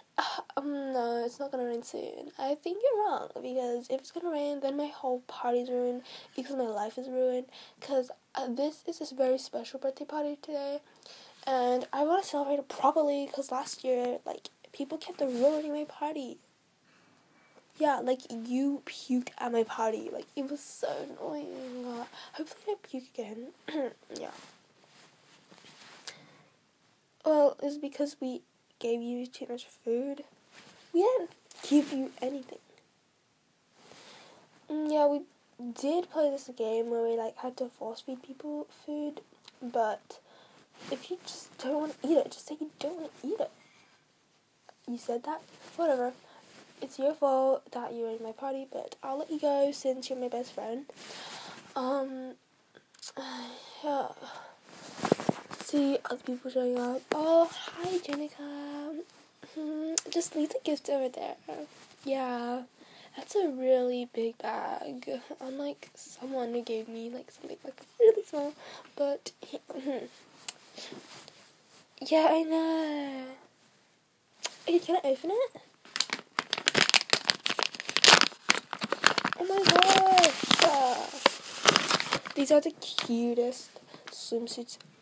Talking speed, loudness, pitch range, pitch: 135 wpm, -30 LUFS, 250-300 Hz, 275 Hz